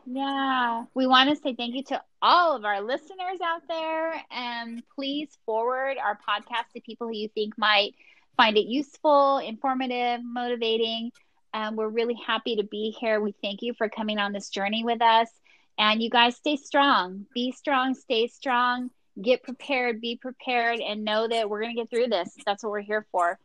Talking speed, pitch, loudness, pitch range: 190 wpm, 240 Hz, -26 LUFS, 220-265 Hz